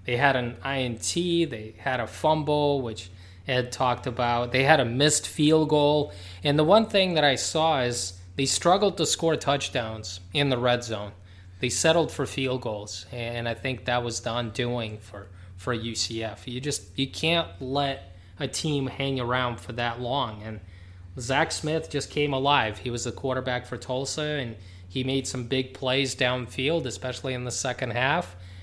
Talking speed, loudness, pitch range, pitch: 180 wpm, -26 LUFS, 110-140 Hz, 125 Hz